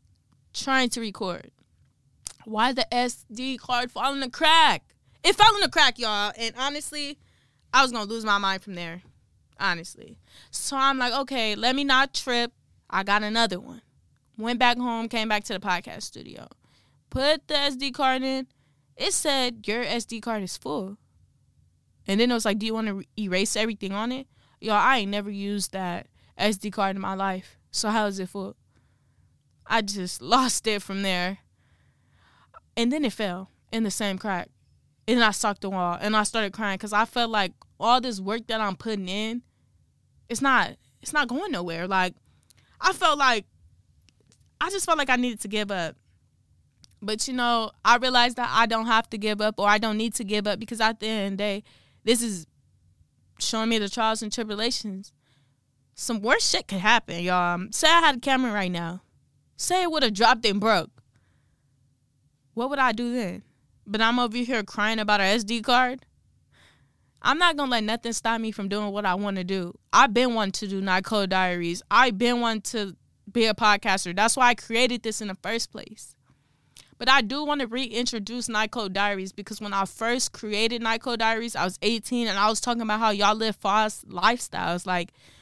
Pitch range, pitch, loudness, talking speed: 200-245 Hz, 220 Hz, -24 LUFS, 200 wpm